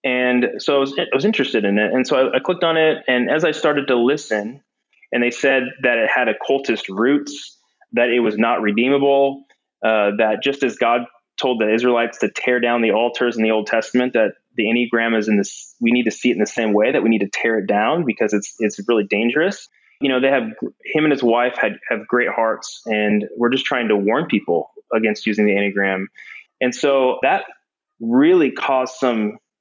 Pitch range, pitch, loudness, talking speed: 110-135 Hz, 120 Hz, -18 LUFS, 215 wpm